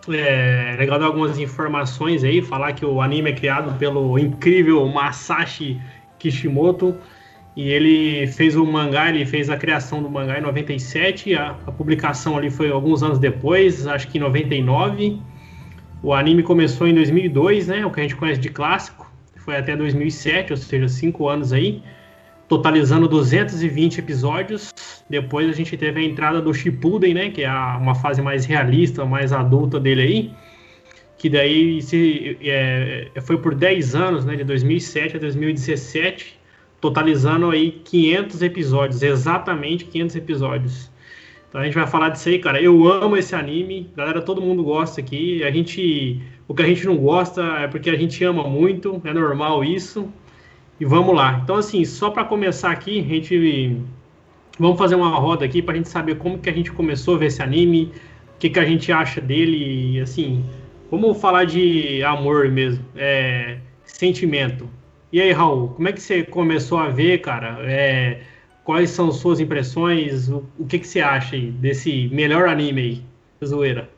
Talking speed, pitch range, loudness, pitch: 170 wpm, 135-170 Hz, -19 LUFS, 150 Hz